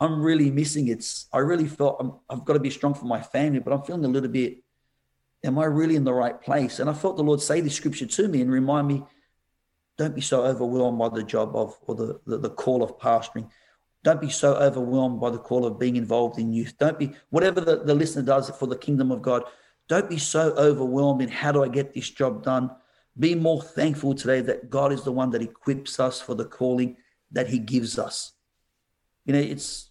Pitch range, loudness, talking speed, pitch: 125-145 Hz, -24 LUFS, 230 wpm, 135 Hz